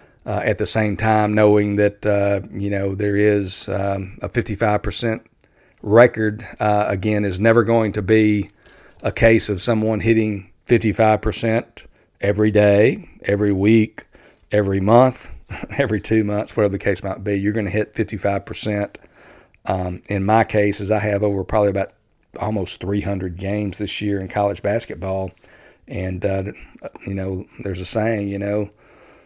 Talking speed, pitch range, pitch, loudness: 155 wpm, 100-110 Hz, 105 Hz, -19 LUFS